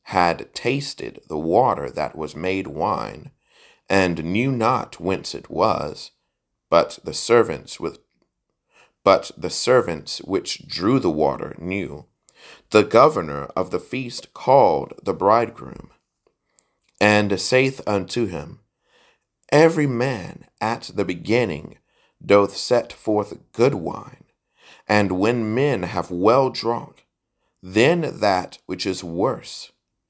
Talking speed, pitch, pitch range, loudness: 120 wpm, 100 Hz, 90-125 Hz, -21 LUFS